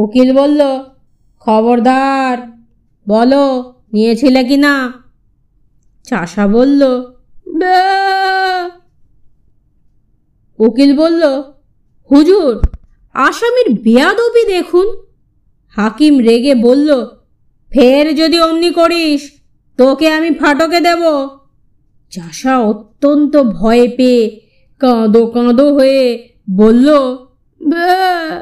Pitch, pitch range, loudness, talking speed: 275 Hz, 245-320 Hz, -11 LUFS, 70 wpm